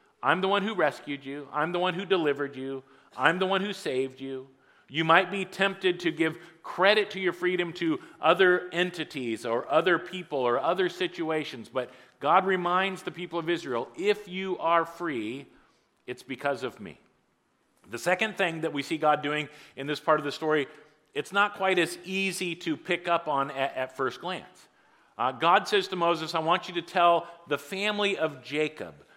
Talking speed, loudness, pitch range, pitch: 190 wpm, -27 LUFS, 145-185 Hz, 165 Hz